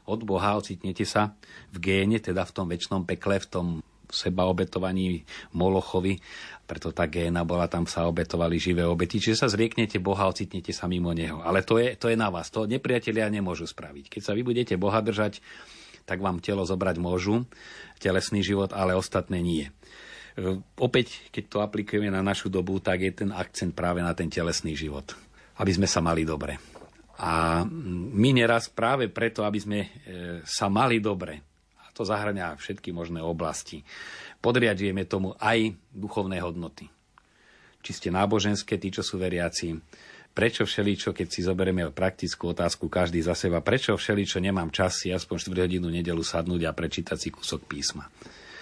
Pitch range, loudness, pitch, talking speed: 85-105 Hz, -27 LUFS, 95 Hz, 165 wpm